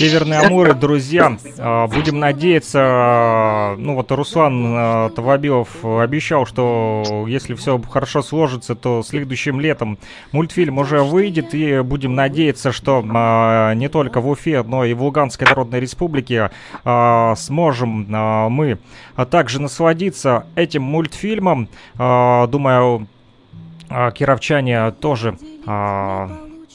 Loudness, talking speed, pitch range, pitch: -16 LUFS, 100 wpm, 115-150 Hz, 130 Hz